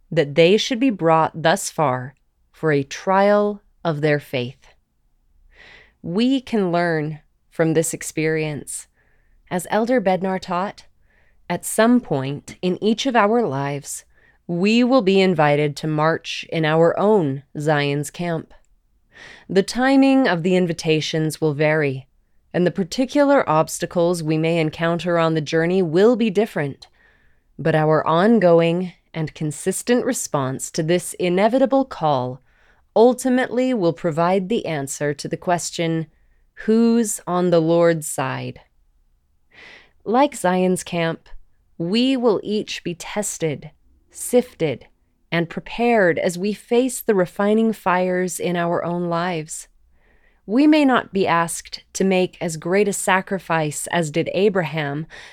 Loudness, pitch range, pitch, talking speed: -20 LUFS, 155-205 Hz, 170 Hz, 130 wpm